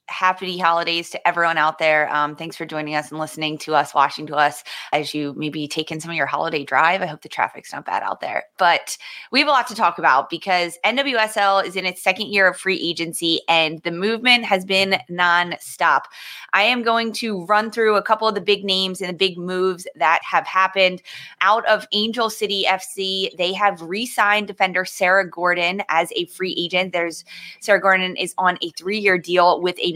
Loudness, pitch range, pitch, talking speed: -19 LUFS, 165-200 Hz, 185 Hz, 210 wpm